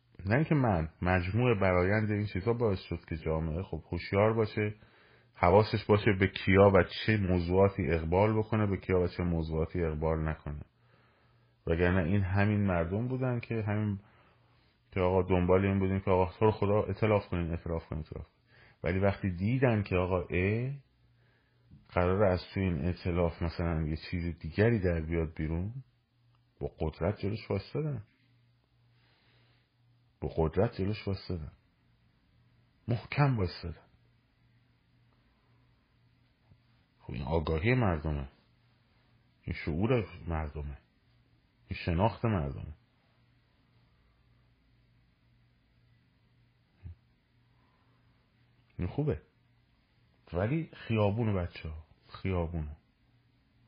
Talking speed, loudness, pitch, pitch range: 105 wpm, -31 LUFS, 105 Hz, 90-120 Hz